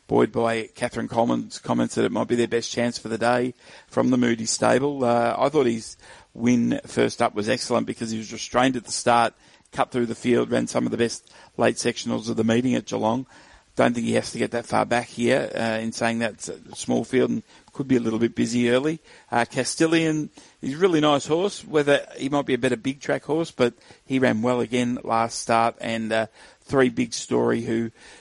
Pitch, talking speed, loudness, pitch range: 120 Hz, 225 wpm, -23 LUFS, 115-130 Hz